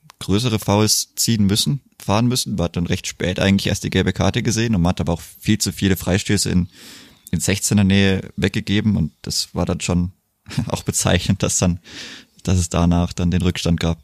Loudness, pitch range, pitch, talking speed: -19 LUFS, 90-105 Hz, 95 Hz, 195 wpm